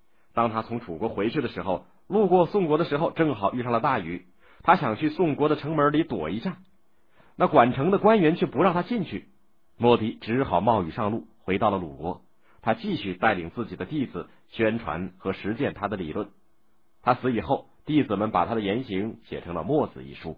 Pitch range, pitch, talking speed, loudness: 110-155 Hz, 120 Hz, 290 characters per minute, -25 LUFS